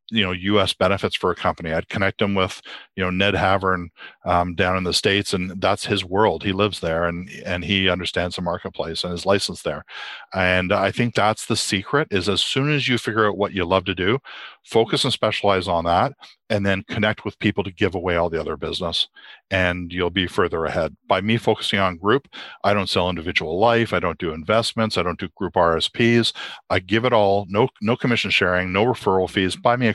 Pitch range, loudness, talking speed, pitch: 90-105 Hz, -21 LUFS, 220 wpm, 95 Hz